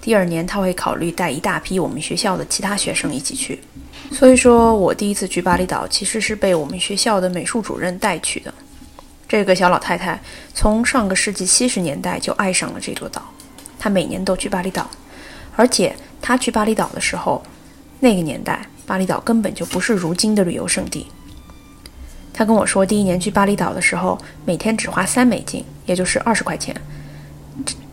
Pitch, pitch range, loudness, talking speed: 195 Hz, 180-220 Hz, -18 LUFS, 295 characters per minute